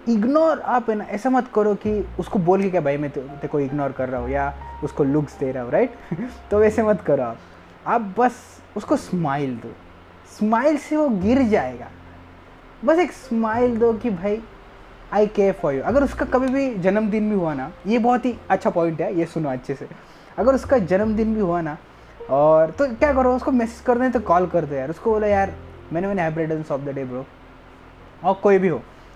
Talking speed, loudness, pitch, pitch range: 210 wpm, -21 LUFS, 195 Hz, 145-235 Hz